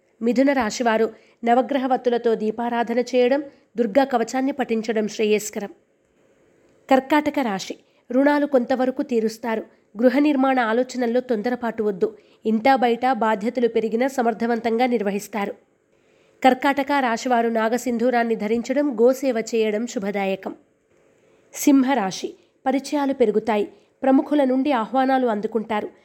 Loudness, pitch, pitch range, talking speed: -21 LUFS, 245 Hz, 225-265 Hz, 90 wpm